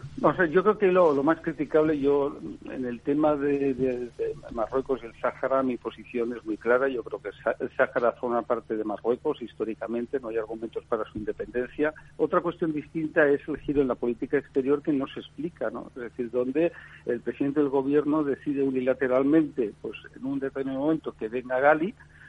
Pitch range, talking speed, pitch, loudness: 120-150 Hz, 200 wpm, 135 Hz, -27 LUFS